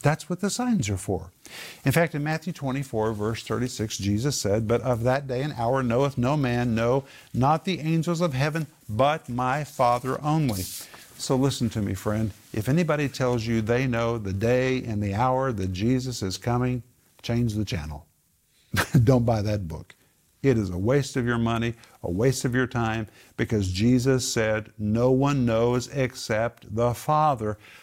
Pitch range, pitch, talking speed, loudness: 110-135 Hz, 120 Hz, 175 wpm, -25 LUFS